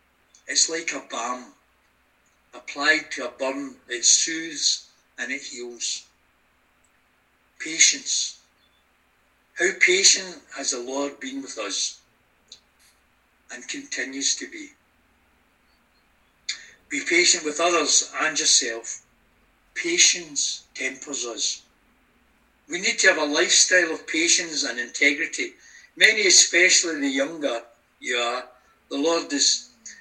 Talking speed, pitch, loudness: 110 wpm, 160 Hz, -21 LUFS